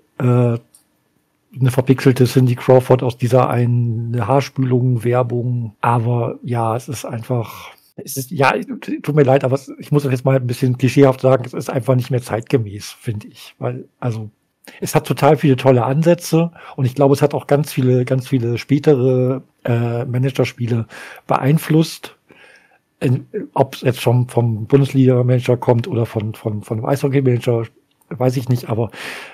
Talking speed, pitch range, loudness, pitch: 160 wpm, 120-140 Hz, -17 LUFS, 130 Hz